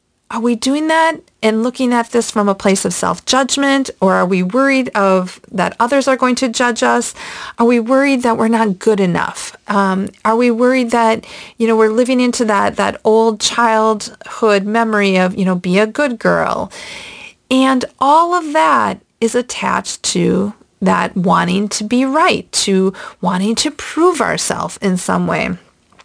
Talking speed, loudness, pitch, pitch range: 175 wpm, -14 LUFS, 230 Hz, 205-260 Hz